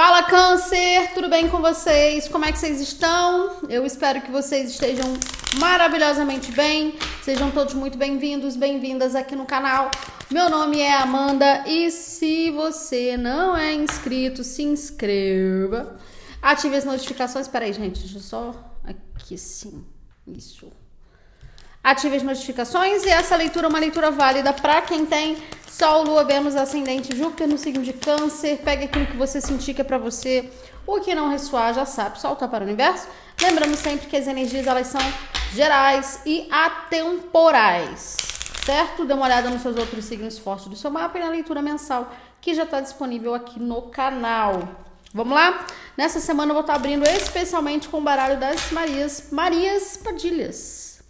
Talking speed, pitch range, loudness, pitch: 165 wpm, 260-320 Hz, -21 LUFS, 285 Hz